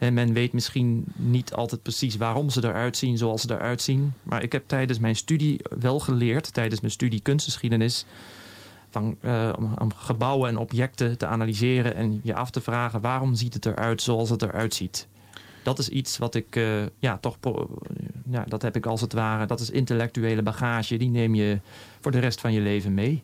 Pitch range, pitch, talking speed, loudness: 110-125 Hz, 120 Hz, 200 wpm, -26 LUFS